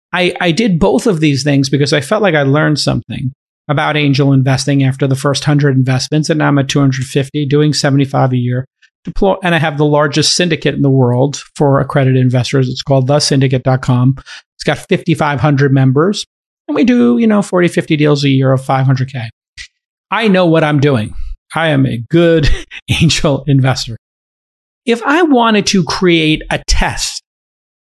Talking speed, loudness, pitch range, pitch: 170 wpm, -12 LUFS, 135-170 Hz, 145 Hz